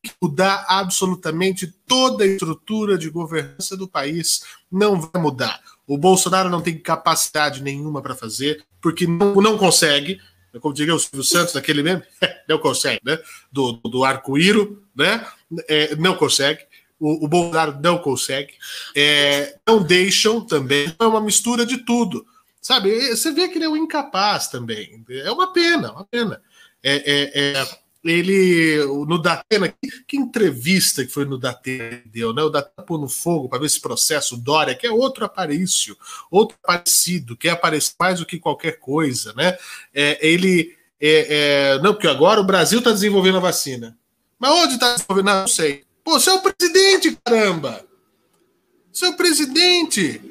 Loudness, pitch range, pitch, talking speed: -18 LUFS, 145-210 Hz, 175 Hz, 160 wpm